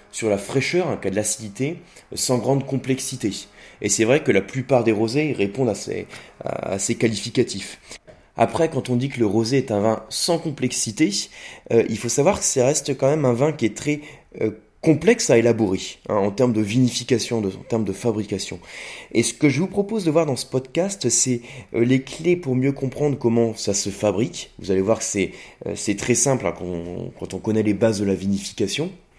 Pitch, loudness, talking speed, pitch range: 120 Hz, -21 LUFS, 215 wpm, 110-135 Hz